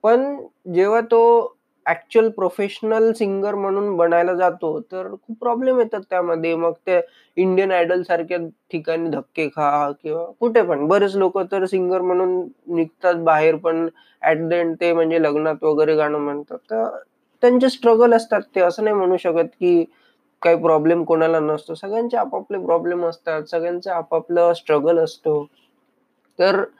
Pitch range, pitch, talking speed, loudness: 165-210 Hz, 175 Hz, 150 wpm, -19 LUFS